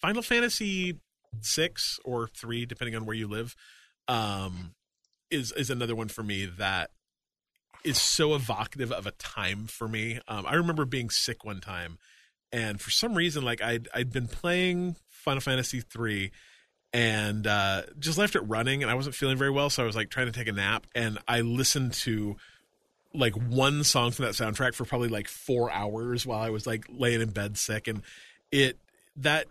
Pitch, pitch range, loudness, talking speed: 120 Hz, 110-135 Hz, -29 LUFS, 185 wpm